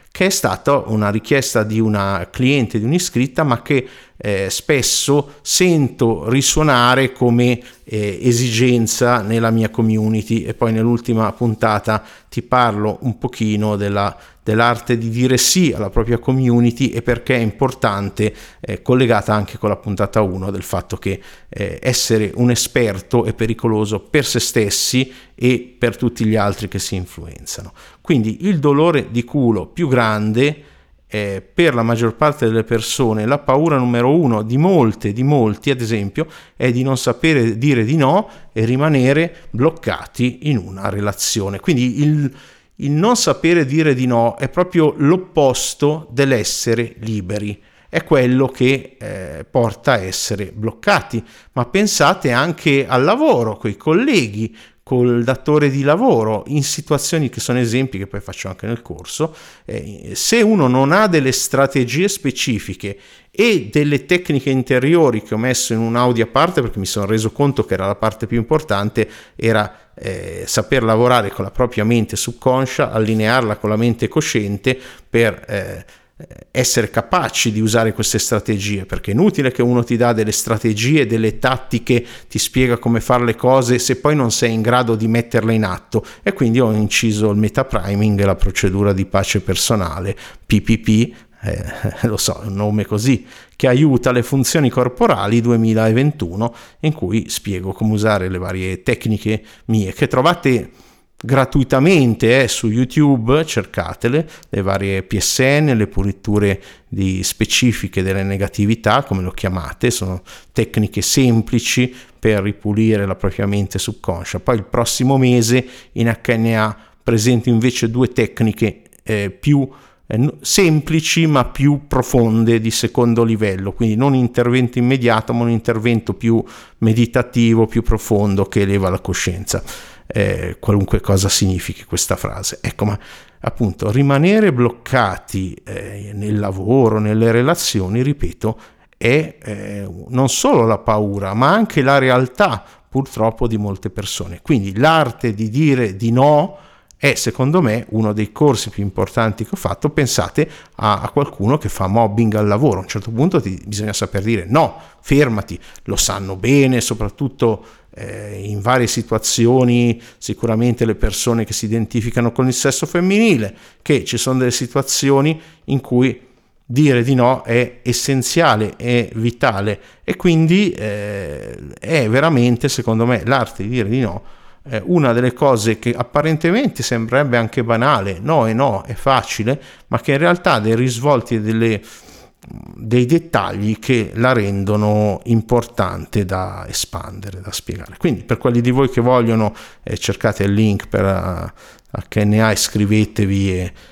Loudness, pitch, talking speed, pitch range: -16 LUFS, 115 Hz, 150 wpm, 105-130 Hz